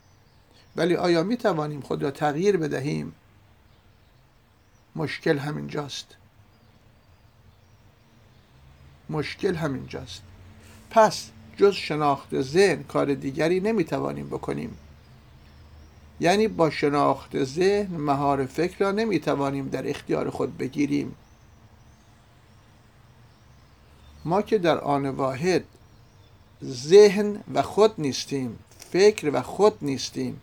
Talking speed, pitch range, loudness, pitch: 95 wpm, 105-150 Hz, -24 LUFS, 120 Hz